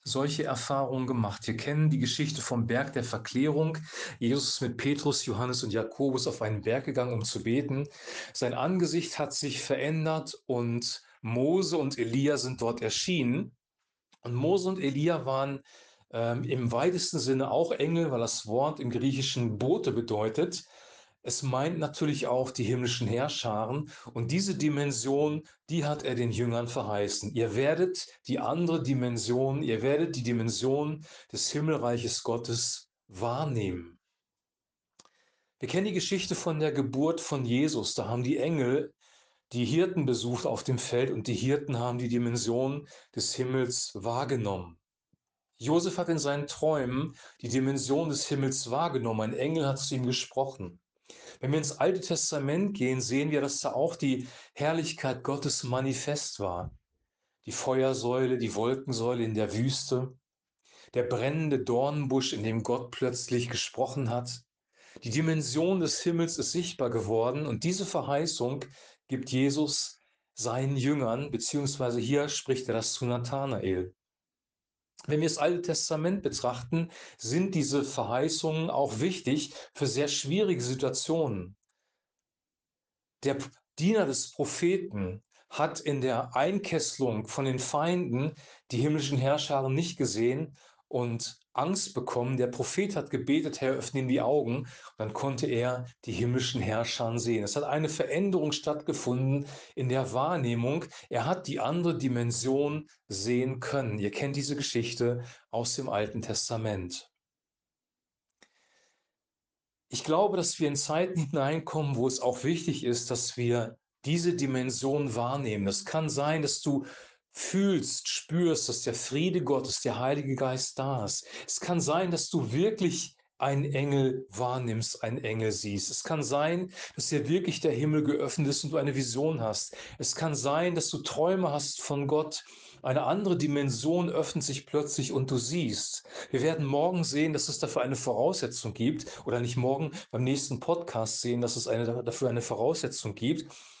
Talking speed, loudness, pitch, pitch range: 150 wpm, -30 LUFS, 135 Hz, 120-155 Hz